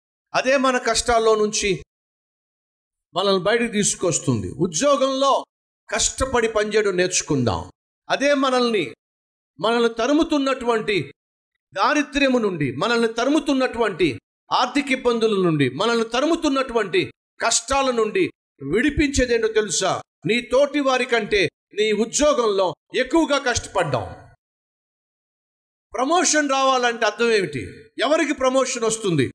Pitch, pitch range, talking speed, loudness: 235 Hz, 215-275 Hz, 90 wpm, -20 LUFS